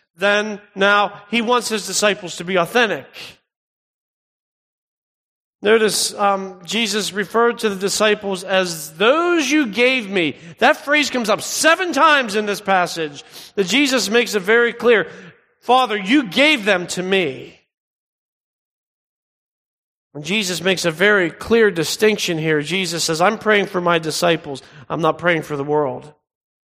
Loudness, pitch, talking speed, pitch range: -17 LUFS, 205 Hz, 140 wpm, 175-230 Hz